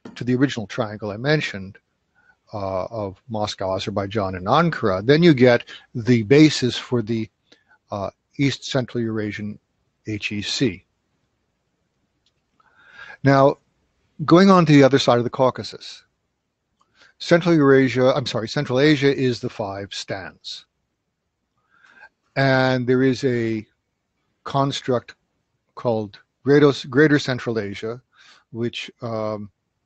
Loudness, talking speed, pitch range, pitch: -20 LUFS, 110 wpm, 110-140 Hz, 125 Hz